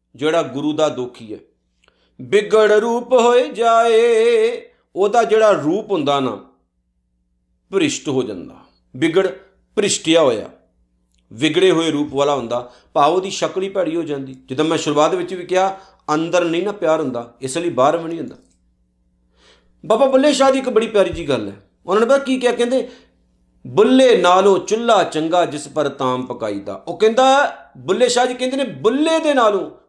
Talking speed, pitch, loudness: 165 wpm, 170 Hz, -17 LUFS